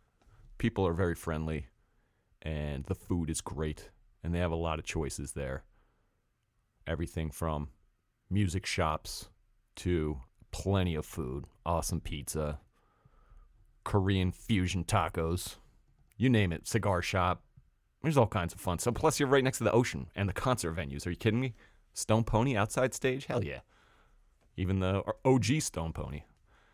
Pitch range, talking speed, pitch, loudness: 80-110 Hz, 150 wpm, 90 Hz, -32 LUFS